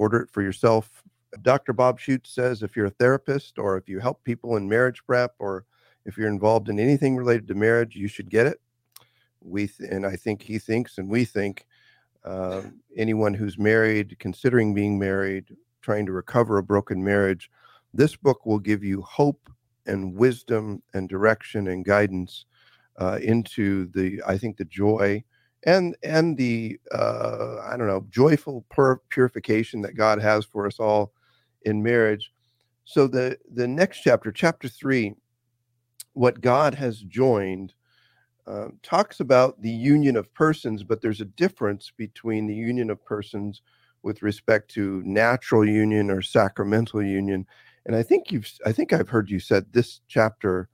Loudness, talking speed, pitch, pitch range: -24 LUFS, 165 wpm, 110 Hz, 100-125 Hz